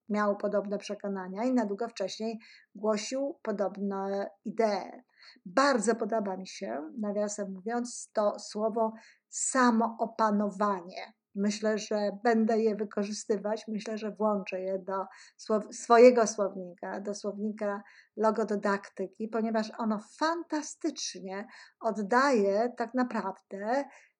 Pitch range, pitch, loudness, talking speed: 205-230 Hz, 215 Hz, -30 LUFS, 100 wpm